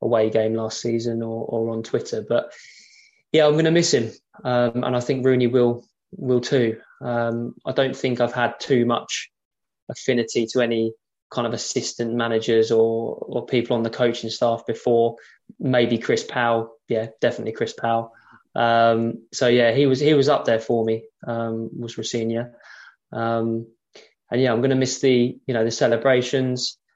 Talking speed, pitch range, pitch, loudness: 180 wpm, 115-125 Hz, 120 Hz, -22 LUFS